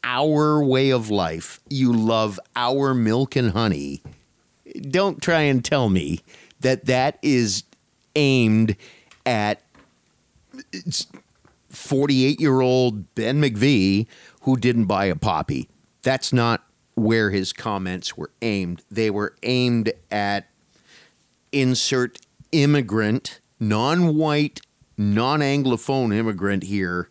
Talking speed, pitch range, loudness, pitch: 110 wpm, 105-135 Hz, -21 LUFS, 120 Hz